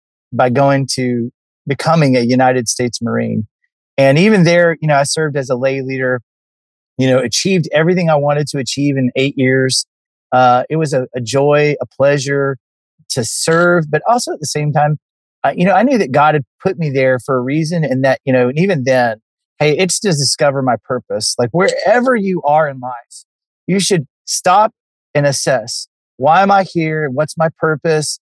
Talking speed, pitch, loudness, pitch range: 195 wpm, 145 Hz, -14 LUFS, 130-160 Hz